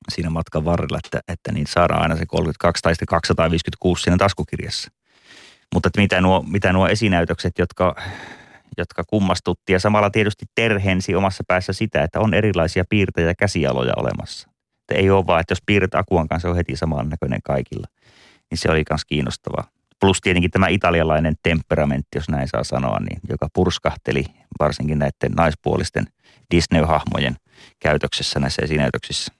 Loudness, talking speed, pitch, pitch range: -20 LUFS, 155 wpm, 85 Hz, 80-95 Hz